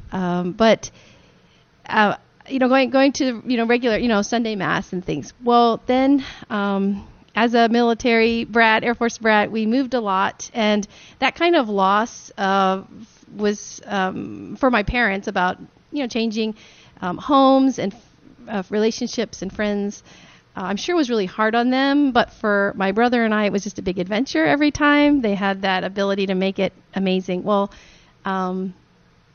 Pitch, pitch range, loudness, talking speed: 220 Hz, 195-240 Hz, -20 LUFS, 180 wpm